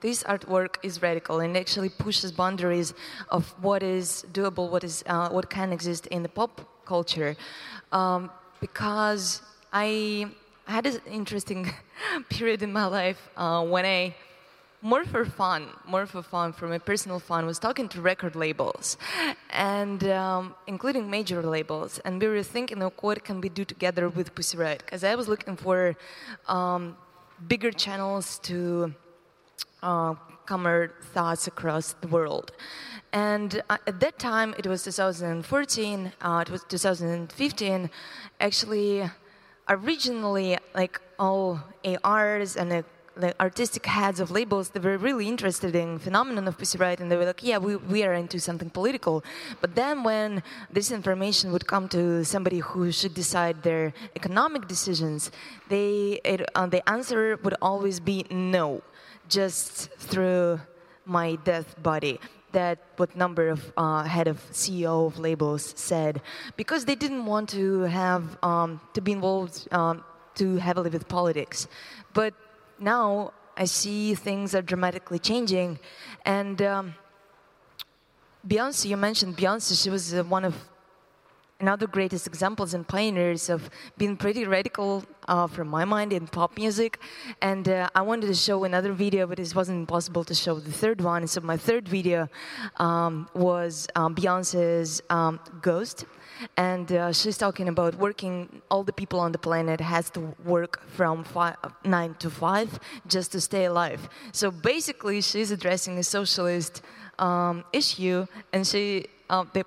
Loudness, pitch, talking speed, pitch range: -27 LUFS, 185 Hz, 150 wpm, 175-200 Hz